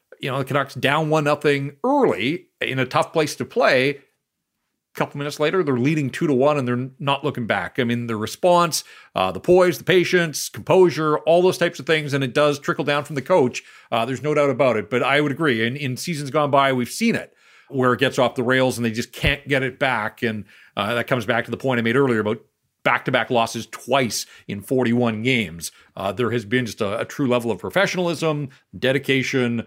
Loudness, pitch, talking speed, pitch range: -21 LUFS, 135 Hz, 230 wpm, 120-150 Hz